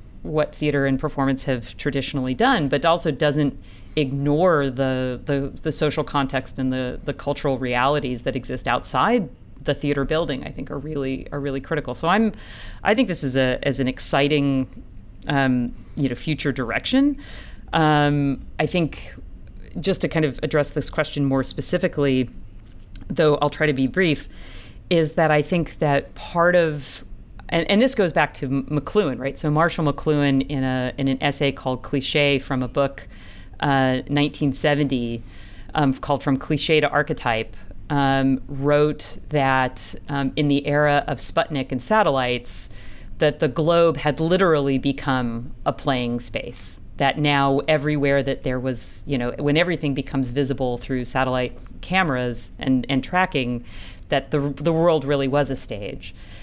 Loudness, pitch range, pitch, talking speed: -22 LUFS, 130-150 Hz, 140 Hz, 160 wpm